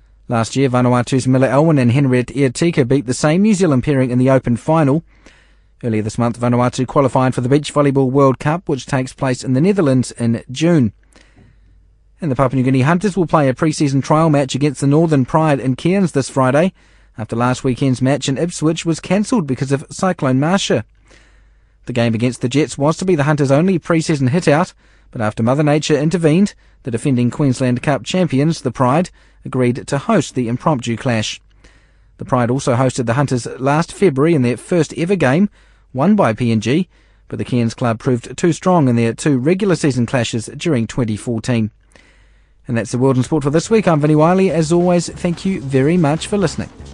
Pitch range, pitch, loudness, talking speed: 125-160 Hz, 135 Hz, -16 LUFS, 195 wpm